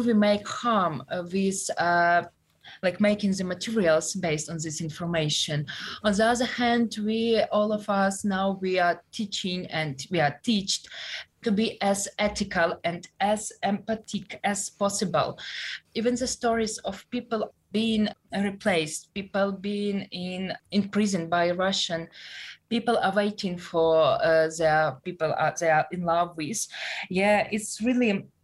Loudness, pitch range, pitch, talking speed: -26 LUFS, 170-215 Hz, 195 Hz, 145 wpm